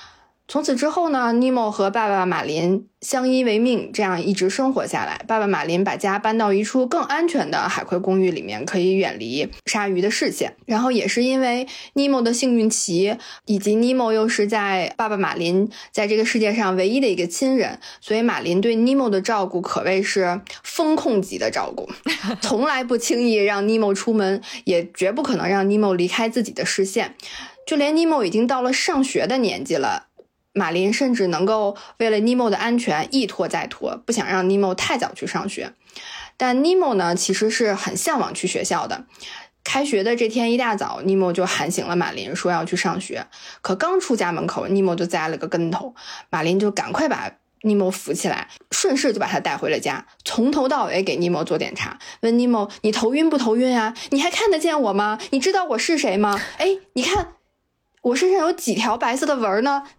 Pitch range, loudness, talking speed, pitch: 190-255 Hz, -21 LUFS, 290 characters per minute, 220 Hz